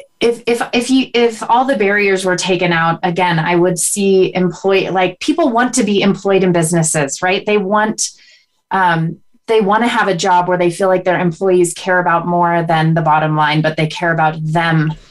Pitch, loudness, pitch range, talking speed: 185 Hz, -14 LUFS, 170-210 Hz, 205 wpm